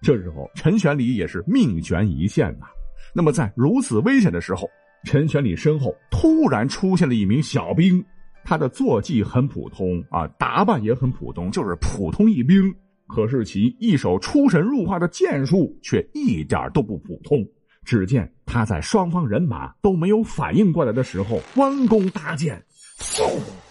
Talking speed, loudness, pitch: 255 characters per minute, -20 LUFS, 170 Hz